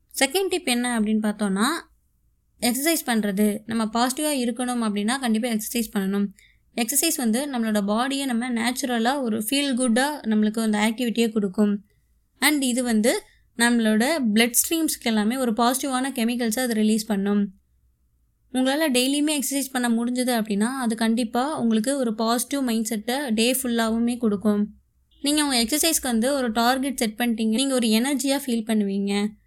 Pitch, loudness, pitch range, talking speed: 235 Hz, -23 LUFS, 220-260 Hz, 140 wpm